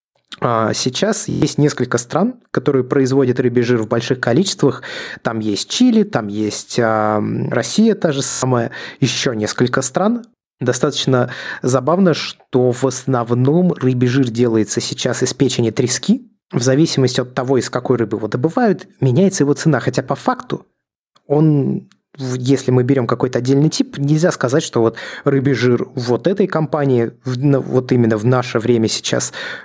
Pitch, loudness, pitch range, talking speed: 130 Hz, -16 LUFS, 125-150 Hz, 145 wpm